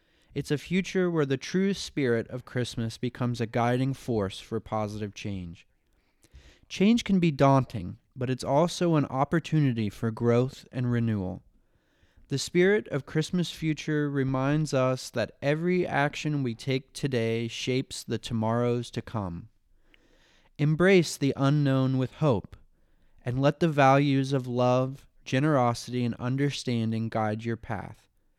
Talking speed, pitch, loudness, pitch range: 135 wpm, 130 Hz, -27 LUFS, 115-145 Hz